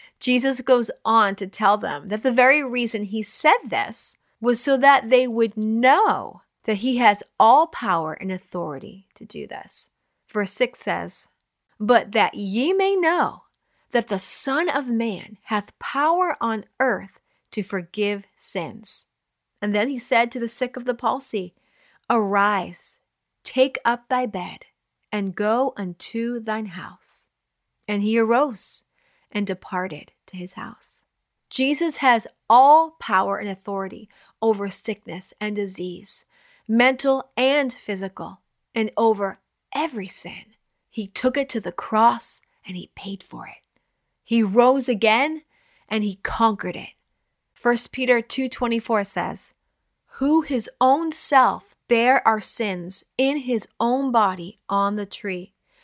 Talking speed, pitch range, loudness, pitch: 140 wpm, 205-260 Hz, -22 LUFS, 225 Hz